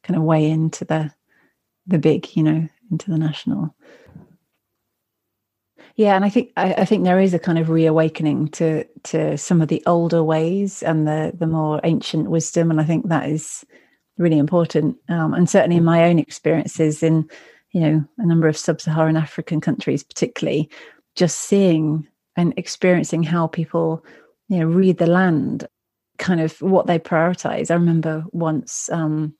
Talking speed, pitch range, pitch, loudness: 165 wpm, 160-175 Hz, 165 Hz, -19 LUFS